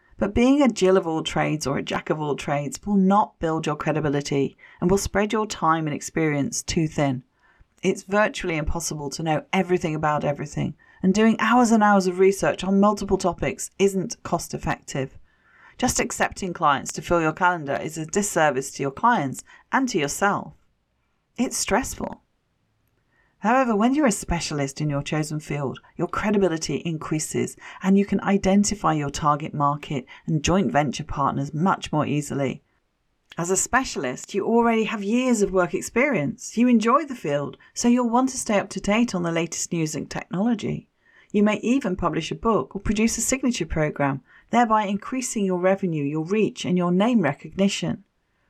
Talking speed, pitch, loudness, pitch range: 175 wpm, 185 Hz, -23 LUFS, 155-210 Hz